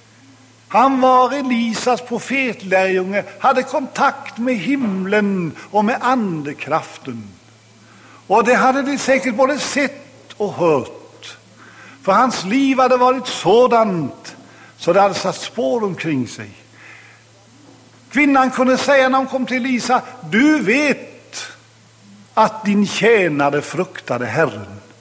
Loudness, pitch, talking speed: -17 LUFS, 210 Hz, 115 wpm